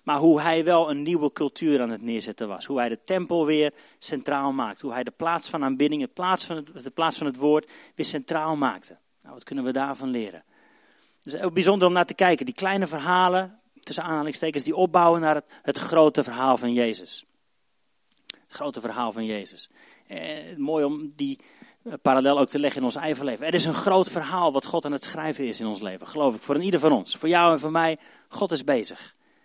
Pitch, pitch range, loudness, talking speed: 155 Hz, 140-175 Hz, -24 LUFS, 210 wpm